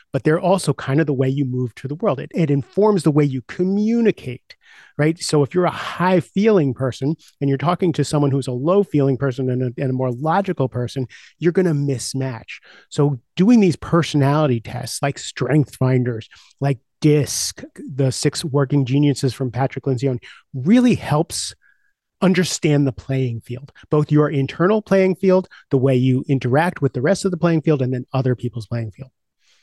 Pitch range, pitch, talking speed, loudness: 130-170 Hz, 140 Hz, 180 wpm, -19 LUFS